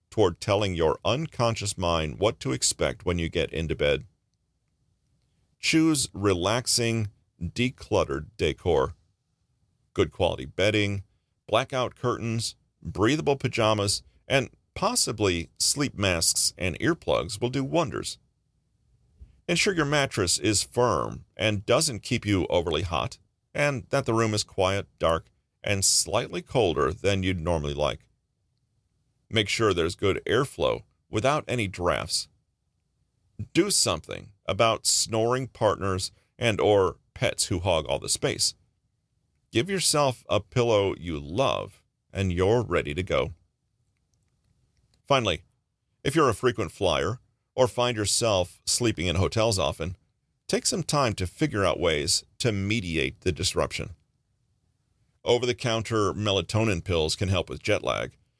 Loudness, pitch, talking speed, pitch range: -26 LUFS, 110 Hz, 125 wpm, 95-125 Hz